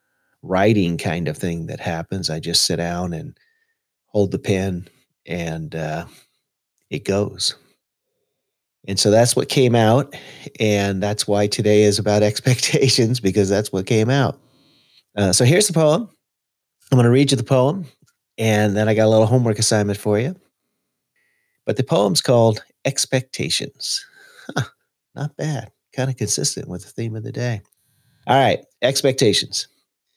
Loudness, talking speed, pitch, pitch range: -19 LUFS, 155 wpm, 115 Hz, 100-140 Hz